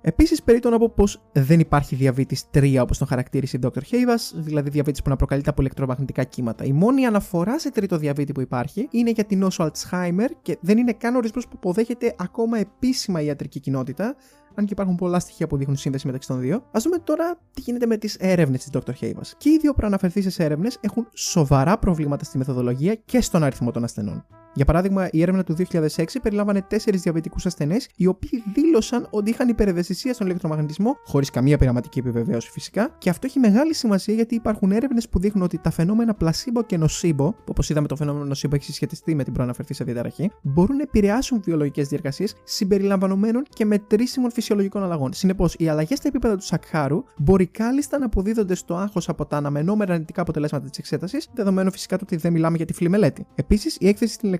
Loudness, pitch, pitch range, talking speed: -22 LUFS, 180 Hz, 145-220 Hz, 200 wpm